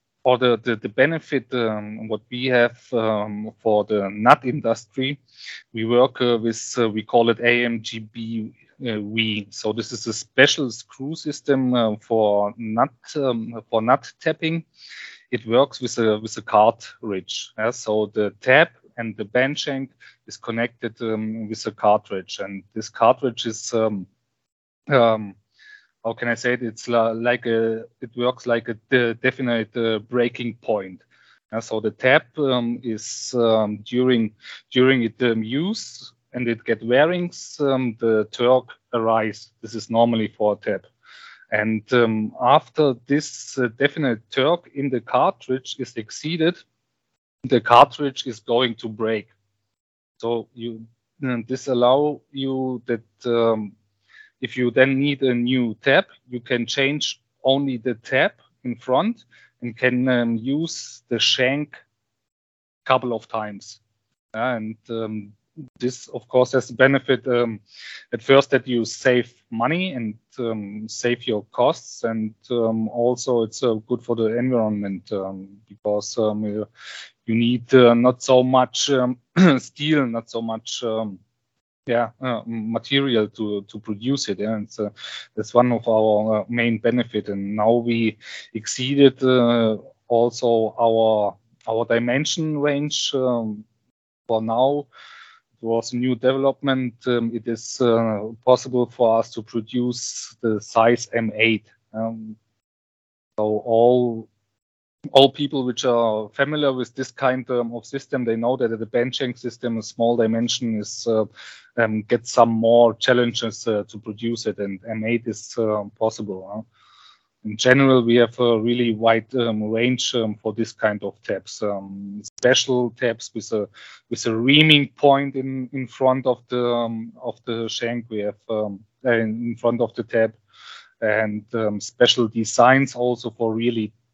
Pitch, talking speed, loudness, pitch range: 115 Hz, 150 wpm, -21 LUFS, 110-125 Hz